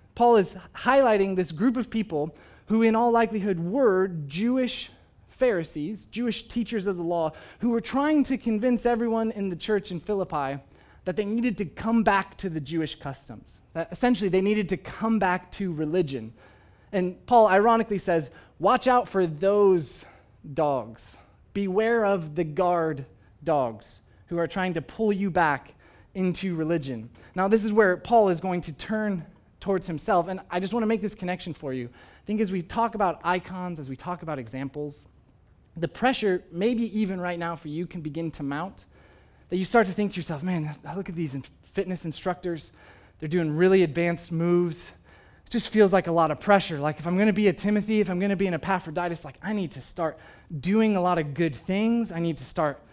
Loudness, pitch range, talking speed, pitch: -26 LUFS, 155-210 Hz, 200 wpm, 180 Hz